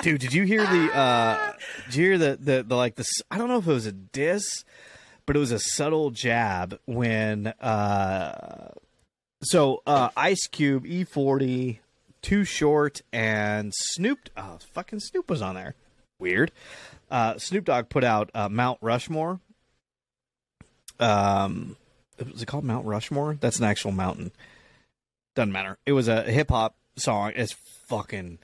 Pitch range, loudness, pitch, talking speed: 105-150 Hz, -25 LUFS, 125 Hz, 155 wpm